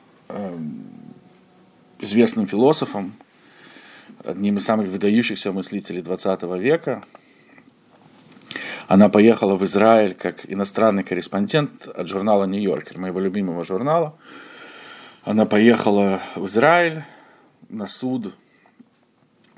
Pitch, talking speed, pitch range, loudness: 105 Hz, 85 wpm, 95-130 Hz, -20 LUFS